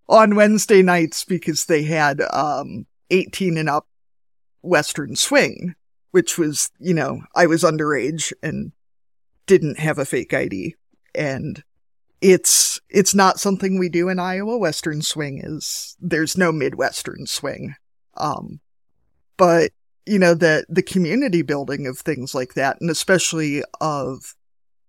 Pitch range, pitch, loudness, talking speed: 150-185 Hz, 170 Hz, -19 LUFS, 135 wpm